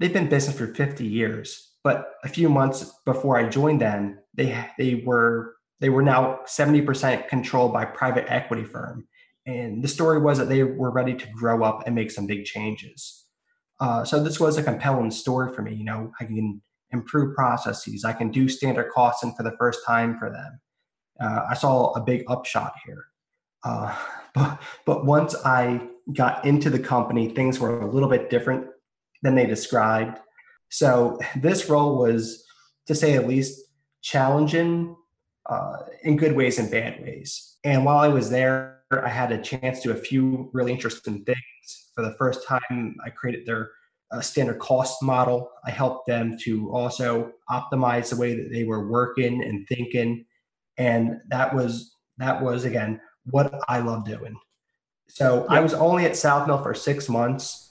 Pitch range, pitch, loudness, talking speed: 115-135 Hz, 125 Hz, -23 LUFS, 180 wpm